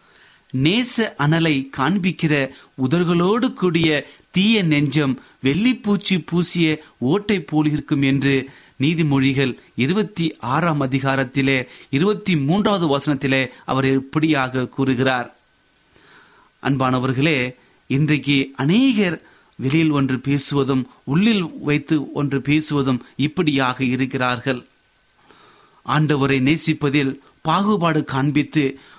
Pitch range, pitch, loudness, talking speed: 135-165 Hz, 145 Hz, -19 LUFS, 70 wpm